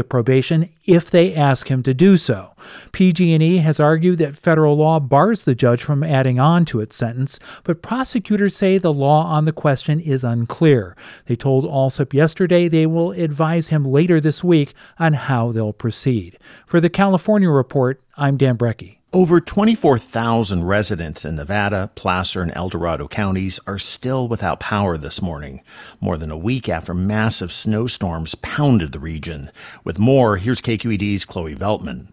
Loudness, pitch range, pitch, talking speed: -17 LUFS, 105-160 Hz, 130 Hz, 165 wpm